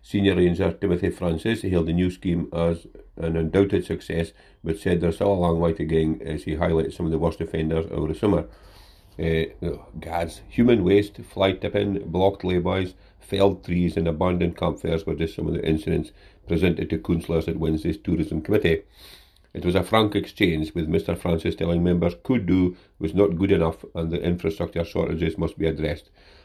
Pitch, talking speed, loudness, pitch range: 85 Hz, 190 wpm, -24 LUFS, 80-95 Hz